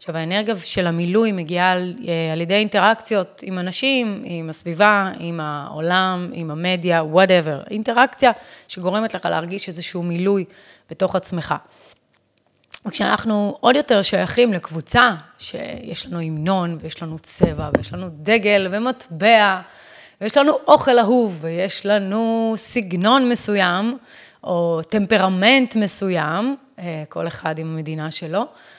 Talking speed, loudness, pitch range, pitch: 120 wpm, -19 LUFS, 170-220 Hz, 190 Hz